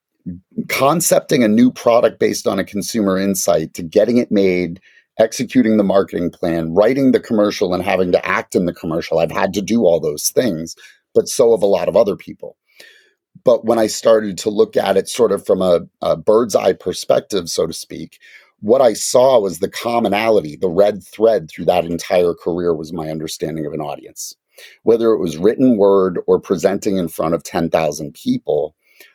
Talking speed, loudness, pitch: 190 wpm, -16 LUFS, 110 Hz